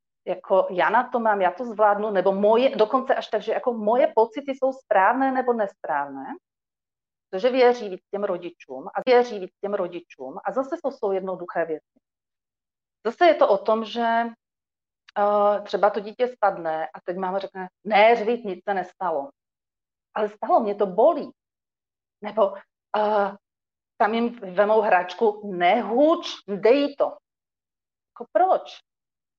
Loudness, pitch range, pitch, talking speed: -23 LUFS, 190-245 Hz, 210 Hz, 150 wpm